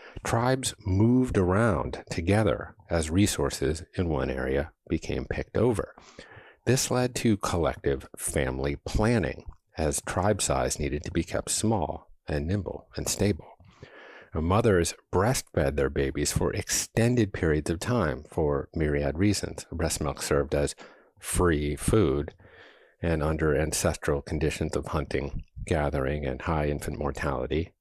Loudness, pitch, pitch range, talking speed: -28 LUFS, 80 Hz, 75-100 Hz, 125 wpm